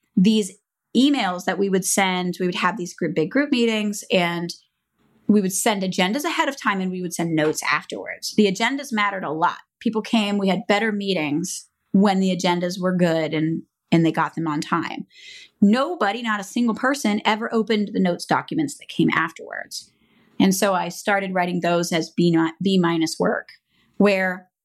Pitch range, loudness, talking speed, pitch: 175-215 Hz, -21 LUFS, 185 wpm, 190 Hz